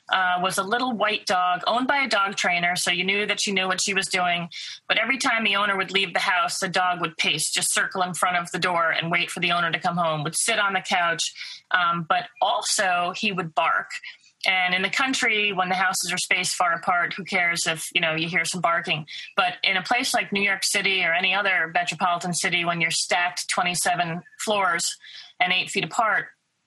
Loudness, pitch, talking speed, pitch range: -22 LUFS, 185 Hz, 230 wpm, 175-205 Hz